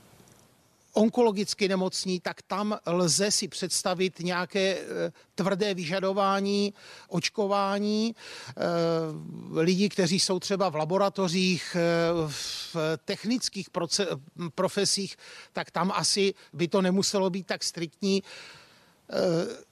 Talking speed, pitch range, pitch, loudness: 90 wpm, 175-200 Hz, 190 Hz, -27 LUFS